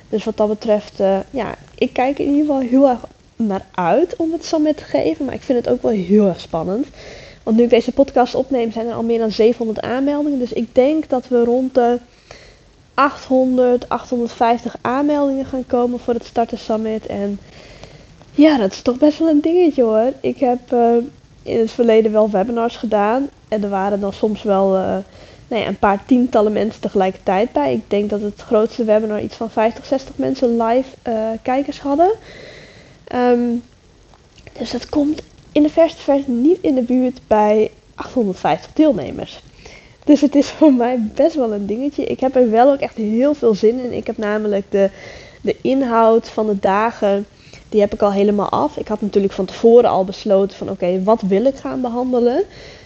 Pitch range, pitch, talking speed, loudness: 215-265 Hz, 235 Hz, 195 wpm, -17 LUFS